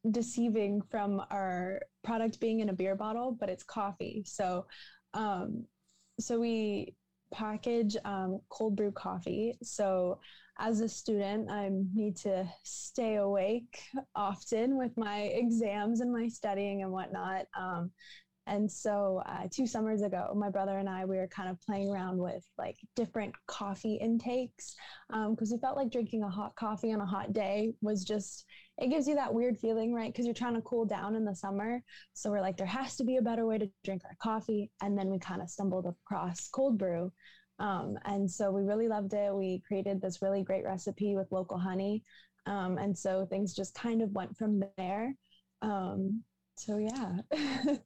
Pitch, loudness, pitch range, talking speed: 205 Hz, -35 LUFS, 195-225 Hz, 180 wpm